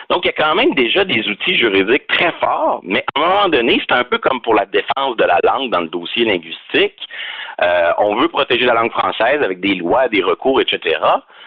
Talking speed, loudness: 230 wpm, -15 LUFS